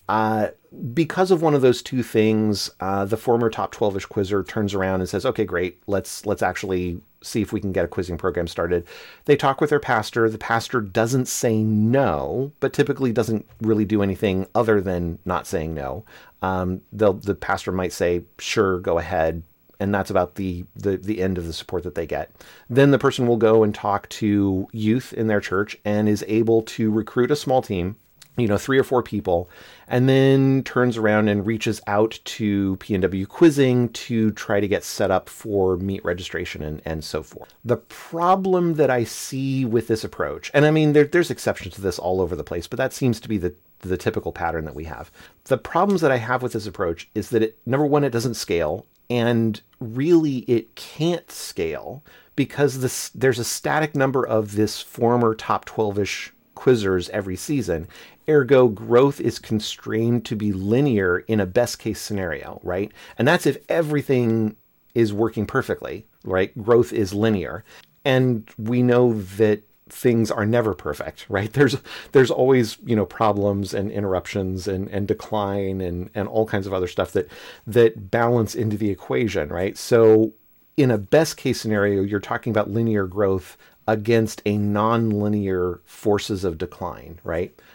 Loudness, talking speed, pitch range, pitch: -22 LUFS, 185 wpm, 100-125 Hz, 110 Hz